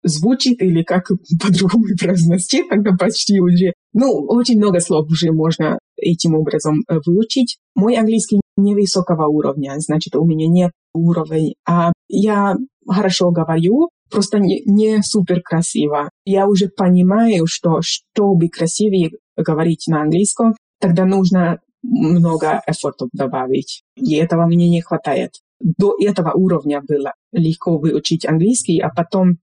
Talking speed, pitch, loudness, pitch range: 130 wpm, 180 Hz, -16 LUFS, 165-205 Hz